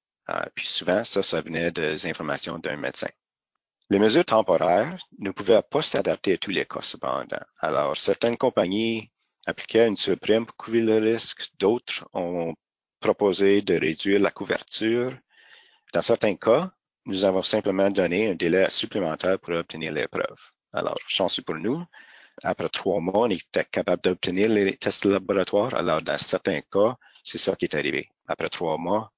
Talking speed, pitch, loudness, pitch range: 165 wpm, 100 Hz, -25 LUFS, 90-110 Hz